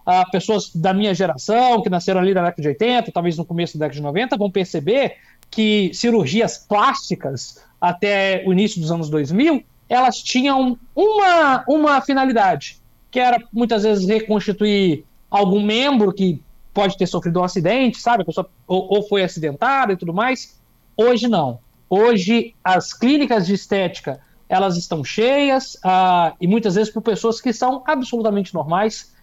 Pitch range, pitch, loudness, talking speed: 180-240 Hz, 205 Hz, -18 LUFS, 160 wpm